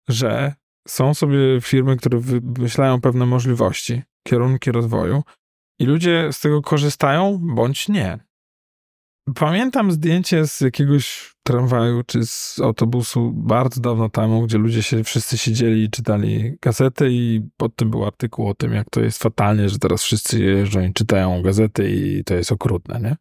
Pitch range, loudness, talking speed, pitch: 110-140 Hz, -19 LUFS, 155 wpm, 120 Hz